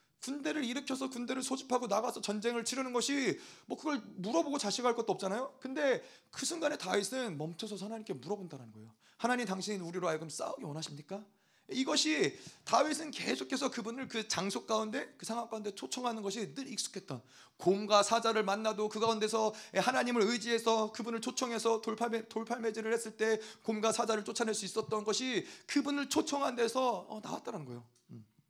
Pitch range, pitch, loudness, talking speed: 205-255 Hz, 225 Hz, -35 LUFS, 395 characters per minute